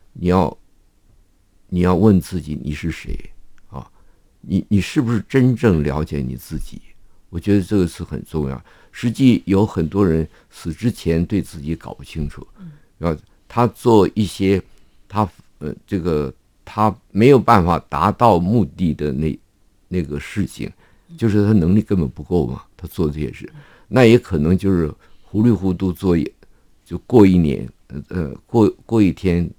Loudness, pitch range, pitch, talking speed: -18 LUFS, 80-105 Hz, 95 Hz, 220 characters per minute